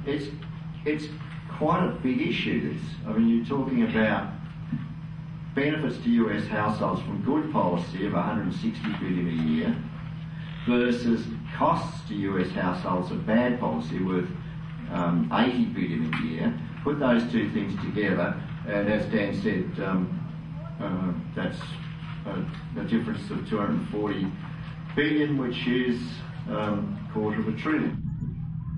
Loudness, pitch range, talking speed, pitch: -28 LUFS, 115-160 Hz, 135 wpm, 150 Hz